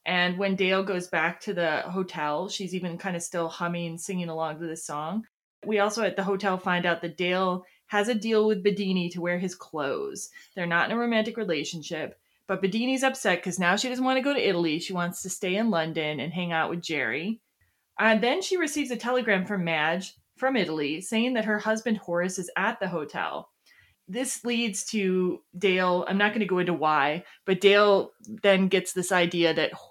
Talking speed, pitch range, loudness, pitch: 210 wpm, 175-215 Hz, -26 LUFS, 190 Hz